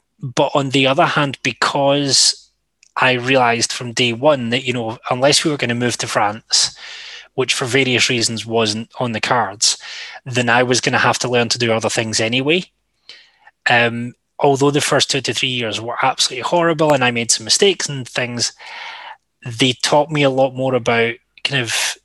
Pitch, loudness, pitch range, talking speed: 130 Hz, -16 LUFS, 120-145 Hz, 190 wpm